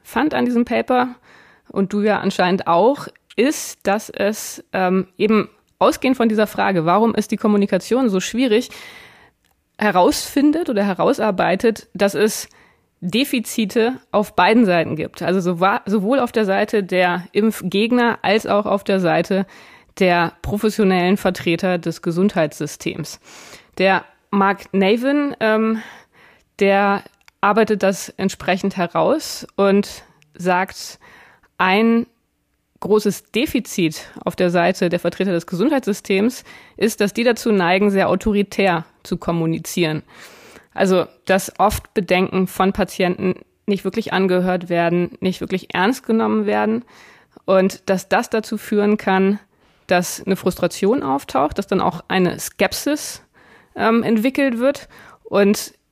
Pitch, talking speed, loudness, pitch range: 195 Hz, 125 wpm, -18 LUFS, 180-220 Hz